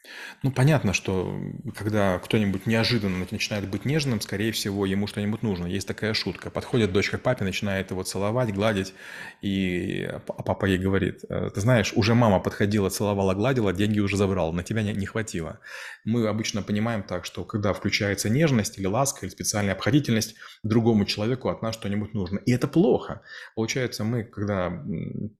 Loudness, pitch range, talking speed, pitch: -25 LUFS, 95-115 Hz, 165 wpm, 105 Hz